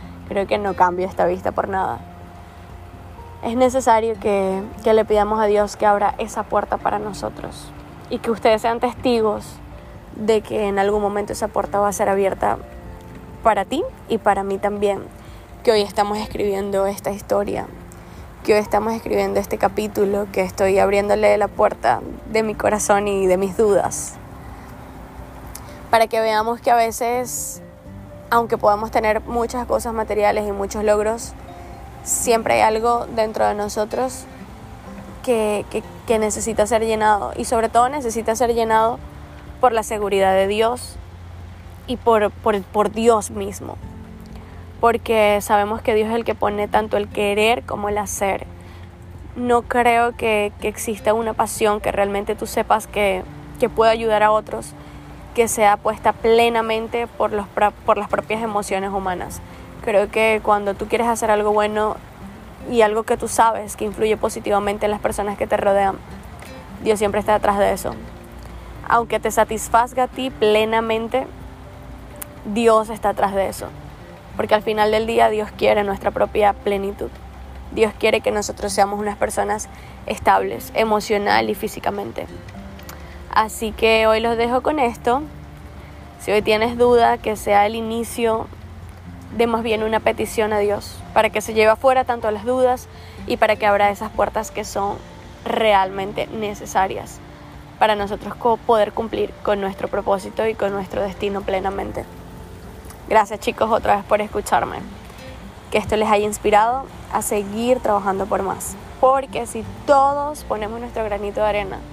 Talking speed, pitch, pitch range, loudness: 155 wpm, 210 Hz, 200-225 Hz, -19 LUFS